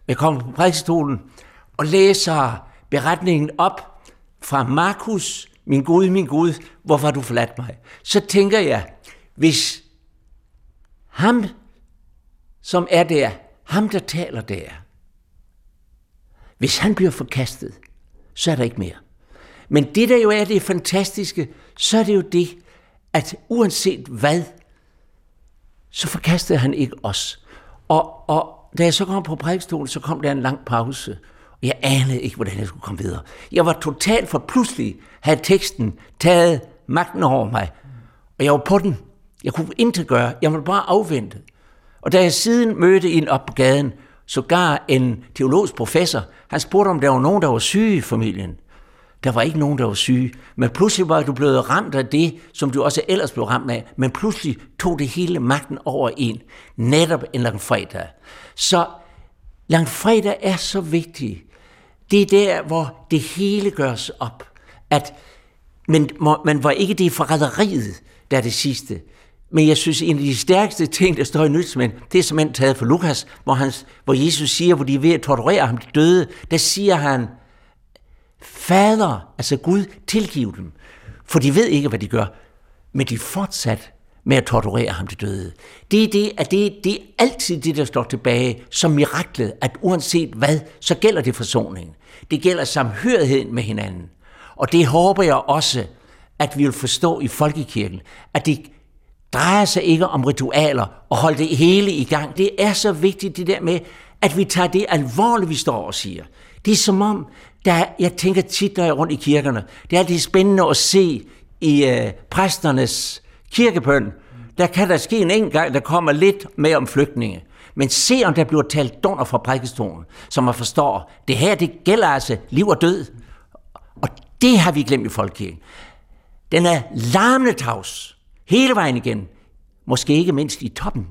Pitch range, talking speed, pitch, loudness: 125-180 Hz, 175 wpm, 150 Hz, -18 LUFS